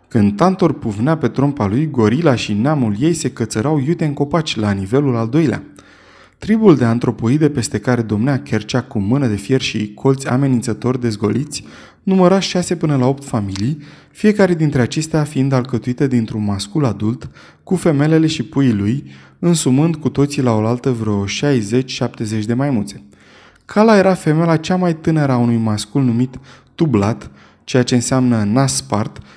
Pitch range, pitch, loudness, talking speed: 115-155 Hz, 130 Hz, -16 LUFS, 155 wpm